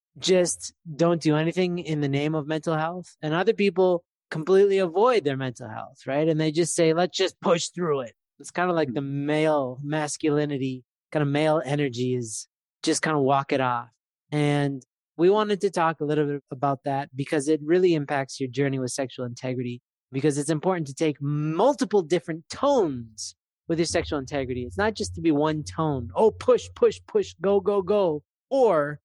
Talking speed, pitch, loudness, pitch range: 190 wpm, 155 Hz, -25 LUFS, 140-175 Hz